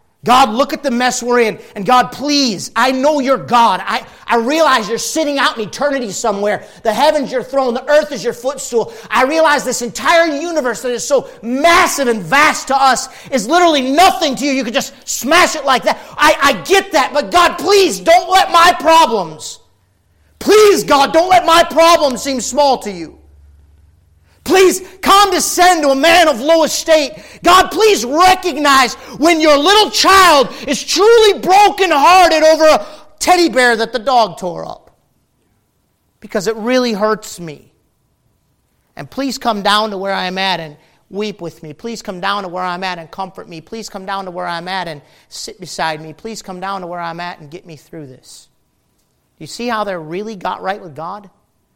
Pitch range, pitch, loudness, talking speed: 205-315 Hz, 260 Hz, -12 LUFS, 190 wpm